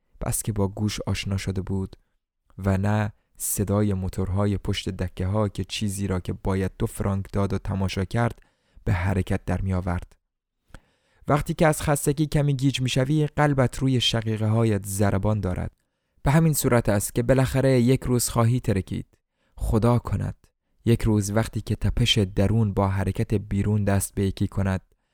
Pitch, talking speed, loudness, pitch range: 105 Hz, 165 wpm, -24 LUFS, 95-120 Hz